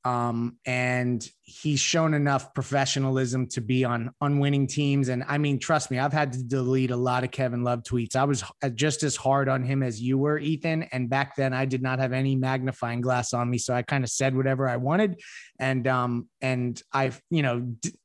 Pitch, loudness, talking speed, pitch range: 130 Hz, -26 LUFS, 215 wpm, 125-140 Hz